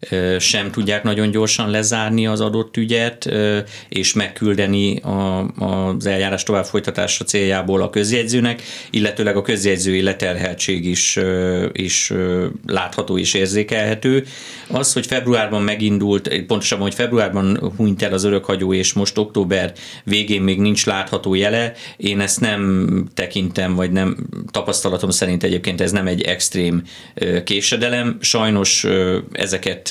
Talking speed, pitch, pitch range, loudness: 120 wpm, 100 Hz, 95-110 Hz, -18 LUFS